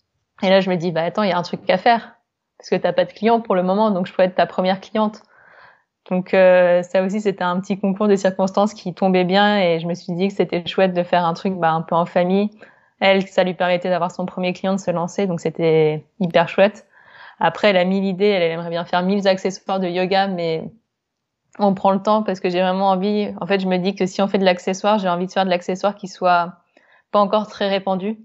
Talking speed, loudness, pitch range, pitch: 255 wpm, -19 LUFS, 180-200 Hz, 190 Hz